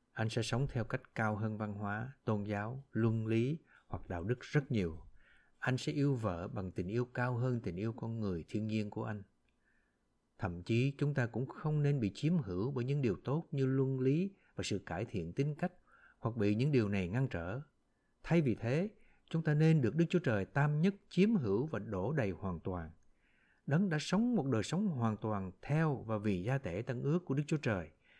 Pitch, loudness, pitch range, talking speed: 120 Hz, -36 LUFS, 105-145 Hz, 220 wpm